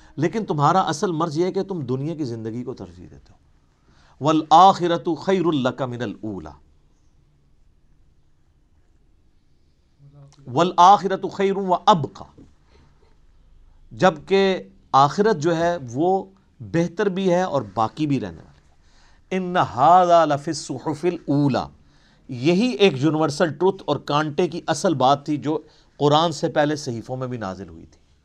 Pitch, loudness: 140 Hz, -20 LUFS